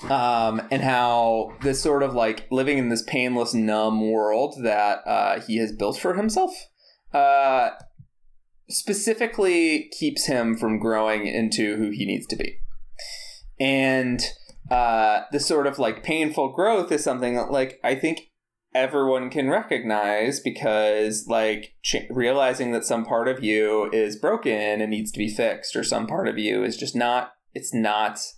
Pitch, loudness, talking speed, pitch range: 120 Hz, -23 LUFS, 160 wpm, 110-140 Hz